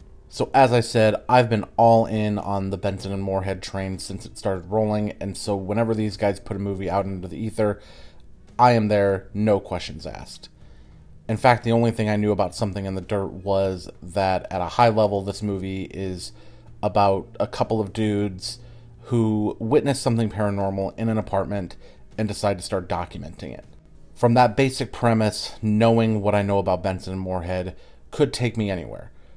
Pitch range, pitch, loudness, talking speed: 95-110 Hz, 100 Hz, -23 LUFS, 185 wpm